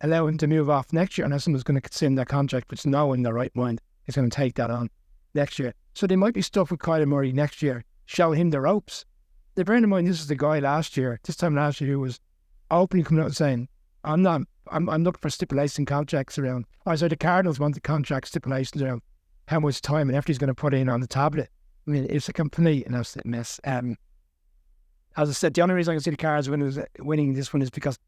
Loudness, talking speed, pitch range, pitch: -25 LUFS, 255 wpm, 130-160 Hz, 145 Hz